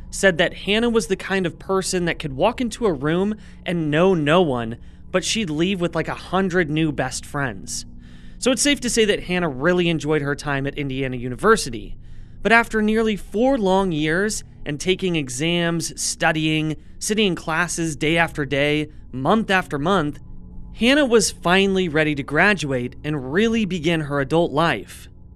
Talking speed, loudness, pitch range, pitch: 175 wpm, -20 LUFS, 145-195 Hz, 165 Hz